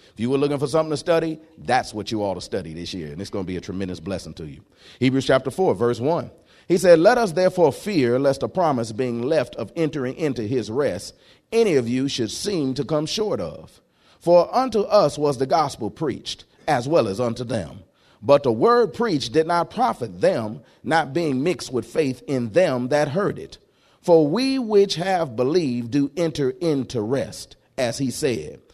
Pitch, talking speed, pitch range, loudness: 145 Hz, 205 wpm, 120-170 Hz, -22 LUFS